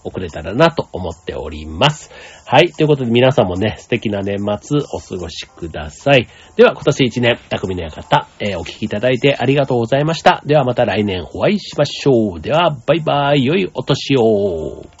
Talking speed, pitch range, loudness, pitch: 370 characters per minute, 100-145 Hz, -16 LUFS, 120 Hz